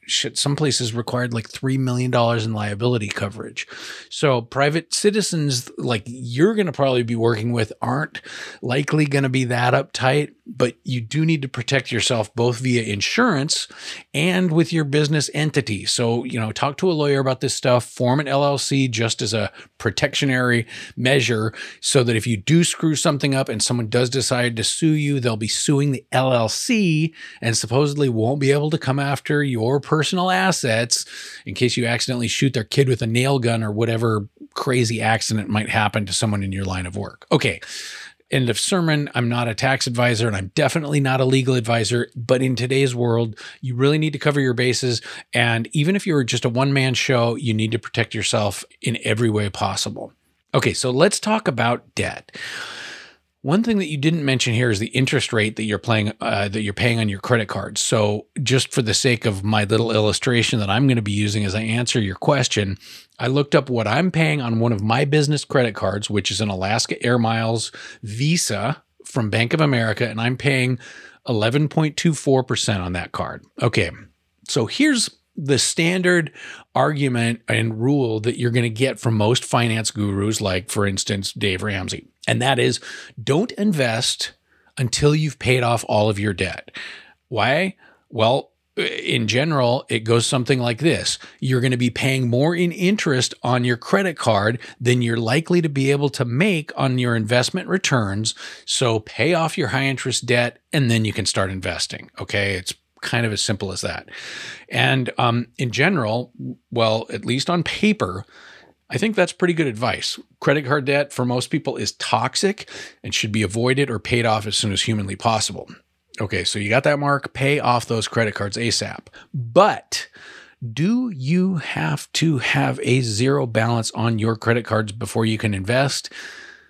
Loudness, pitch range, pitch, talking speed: -20 LUFS, 110-140 Hz, 125 Hz, 185 wpm